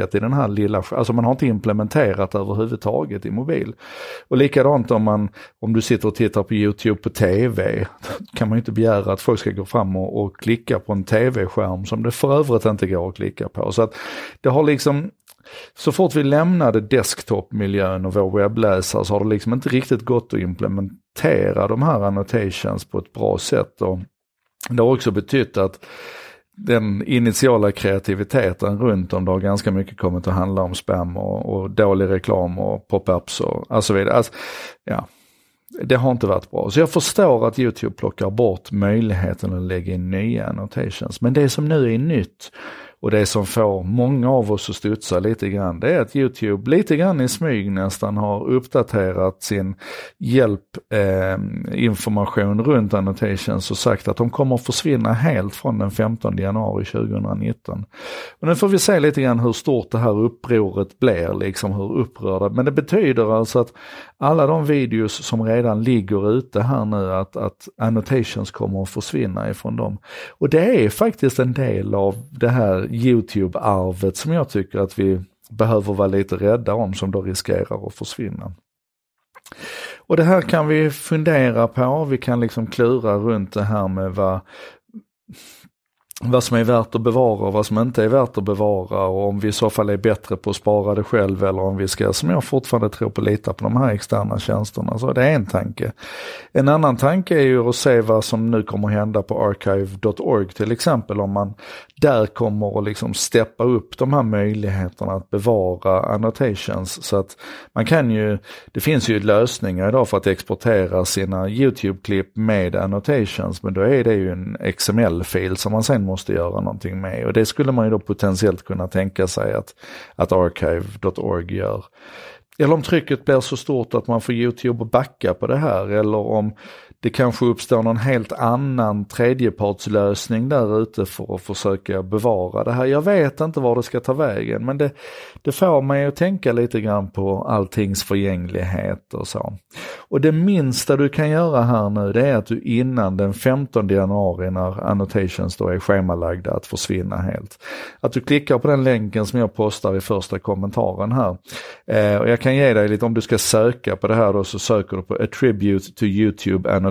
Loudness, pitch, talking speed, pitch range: -19 LUFS, 110 Hz, 185 wpm, 100-125 Hz